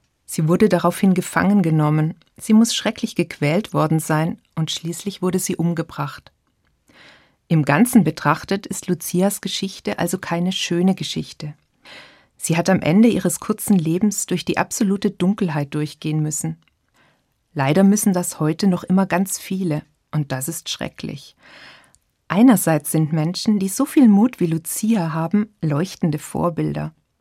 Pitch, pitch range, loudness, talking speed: 175 Hz, 160-200 Hz, -19 LUFS, 140 wpm